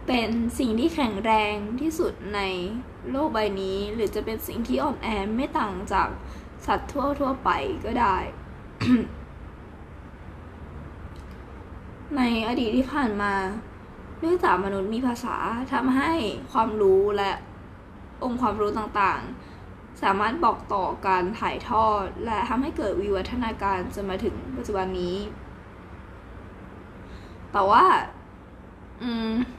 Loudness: -25 LUFS